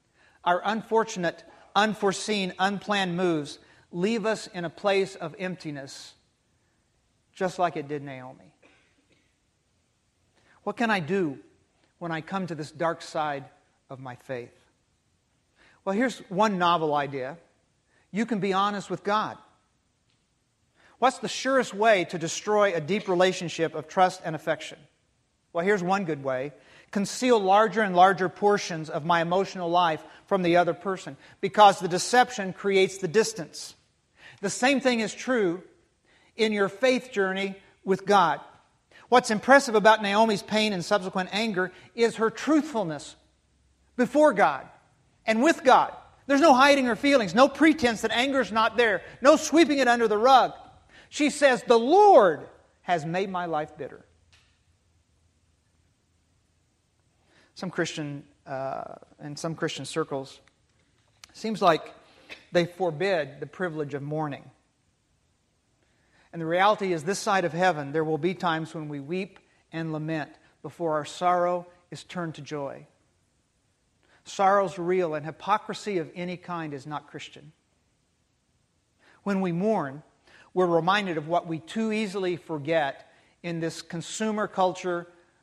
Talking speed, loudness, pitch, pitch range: 140 wpm, -25 LUFS, 180 Hz, 155-205 Hz